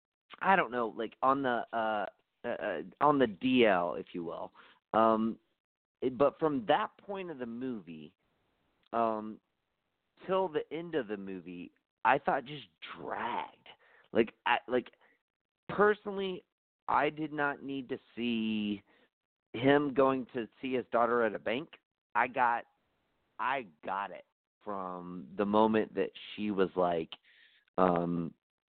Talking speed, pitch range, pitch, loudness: 140 wpm, 105-145 Hz, 120 Hz, -32 LUFS